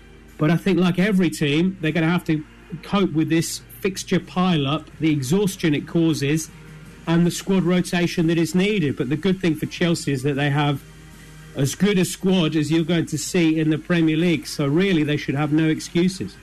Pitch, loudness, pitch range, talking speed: 160 Hz, -21 LUFS, 155-175 Hz, 210 wpm